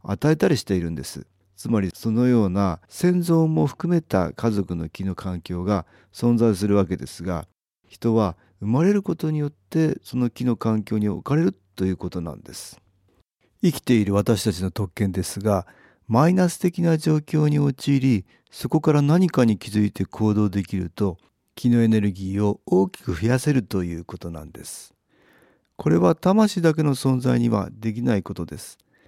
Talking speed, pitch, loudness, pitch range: 330 characters per minute, 110 Hz, -22 LUFS, 95-140 Hz